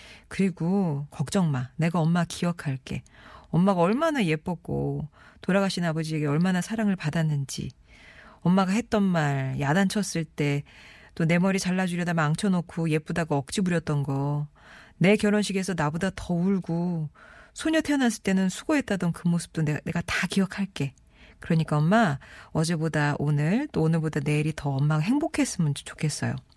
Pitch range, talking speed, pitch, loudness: 150-195 Hz, 330 characters per minute, 170 Hz, -26 LUFS